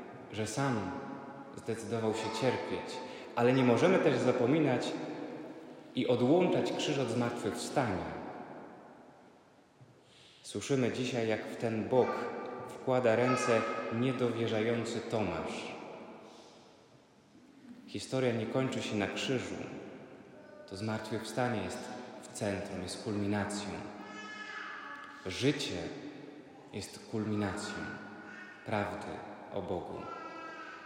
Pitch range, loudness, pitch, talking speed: 105-125 Hz, -34 LUFS, 115 Hz, 85 wpm